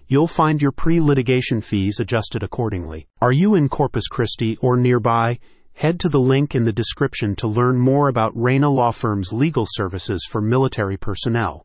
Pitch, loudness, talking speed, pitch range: 120 Hz, -19 LUFS, 170 wpm, 110-140 Hz